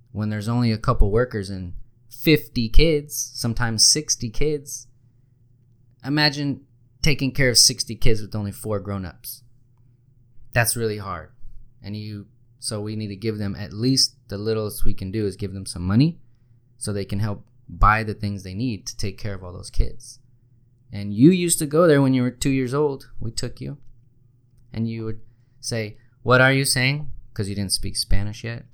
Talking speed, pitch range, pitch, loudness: 190 wpm, 105-125 Hz, 120 Hz, -22 LUFS